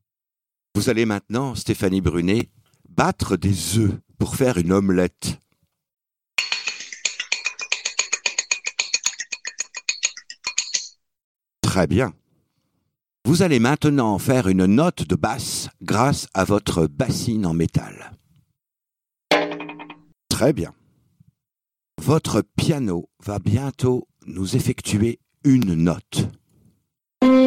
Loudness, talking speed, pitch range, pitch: -21 LUFS, 85 wpm, 95-155 Hz, 115 Hz